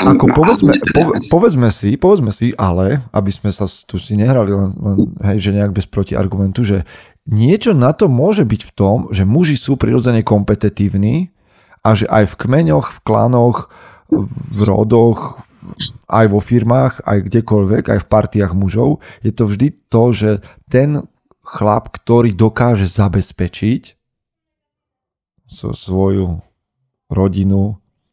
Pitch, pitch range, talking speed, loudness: 105 Hz, 100-120 Hz, 135 wpm, -14 LUFS